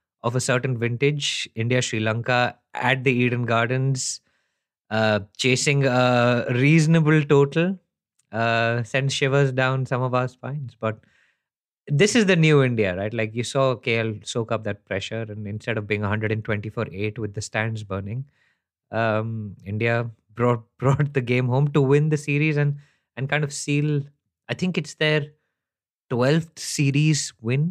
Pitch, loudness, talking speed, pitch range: 125 Hz, -22 LUFS, 155 wpm, 110-145 Hz